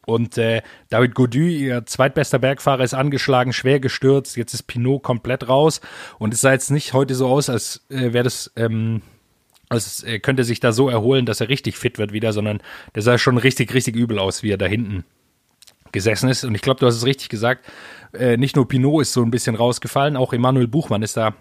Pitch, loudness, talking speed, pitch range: 125 Hz, -19 LUFS, 220 wpm, 115-135 Hz